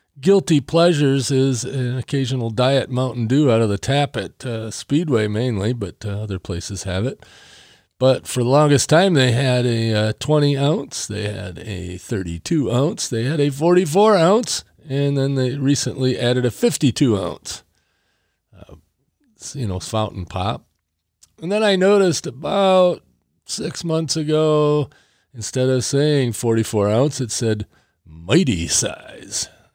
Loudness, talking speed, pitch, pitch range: -19 LUFS, 145 wpm, 130 Hz, 110-150 Hz